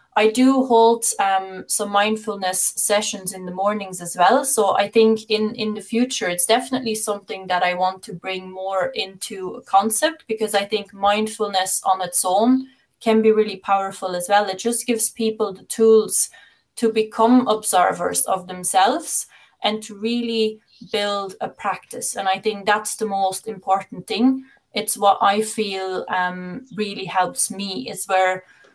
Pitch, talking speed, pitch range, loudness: 210 Hz, 165 wpm, 190-220 Hz, -19 LUFS